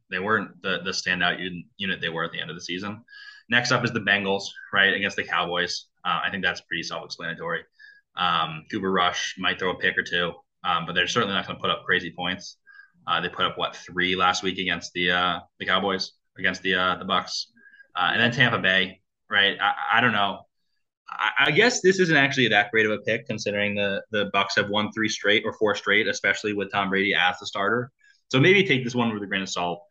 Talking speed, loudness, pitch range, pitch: 235 wpm, -23 LUFS, 90-140 Hz, 105 Hz